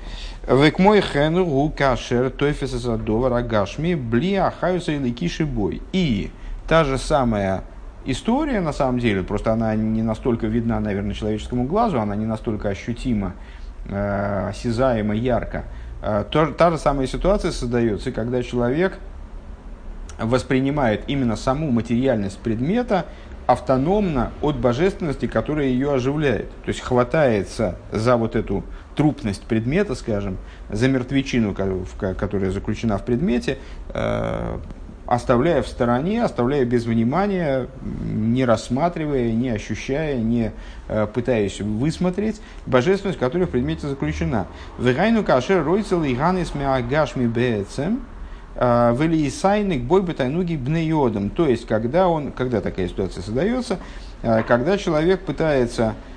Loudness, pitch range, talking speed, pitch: -21 LUFS, 105-150 Hz, 105 wpm, 125 Hz